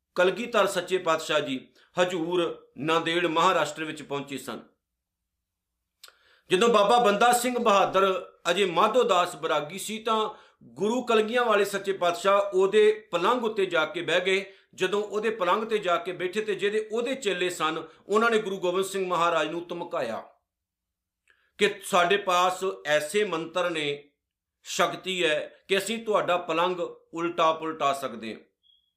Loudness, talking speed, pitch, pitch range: -26 LUFS, 140 wpm, 180 Hz, 160-205 Hz